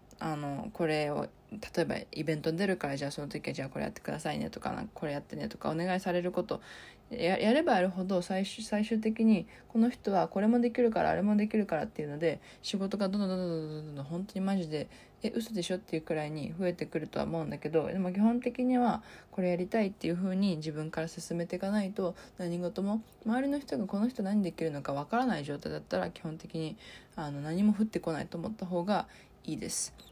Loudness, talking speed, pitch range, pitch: -33 LUFS, 455 characters per minute, 160-210 Hz, 185 Hz